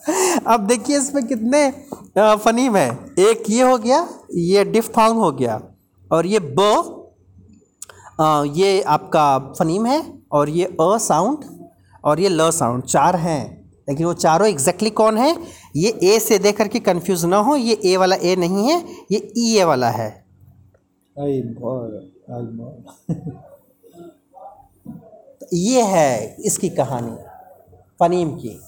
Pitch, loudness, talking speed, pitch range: 185 Hz, -18 LUFS, 135 wpm, 145-230 Hz